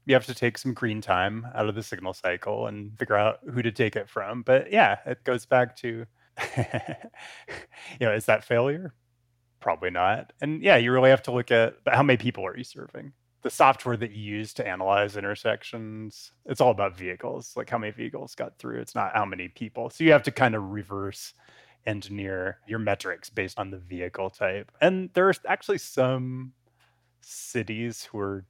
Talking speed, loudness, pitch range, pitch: 195 wpm, -26 LUFS, 105-130 Hz, 115 Hz